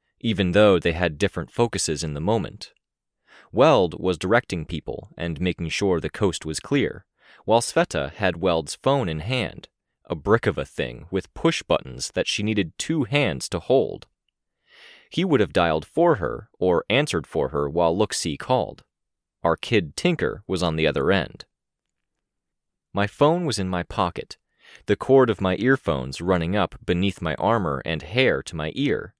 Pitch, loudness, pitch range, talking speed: 90 Hz, -23 LUFS, 80-105 Hz, 175 wpm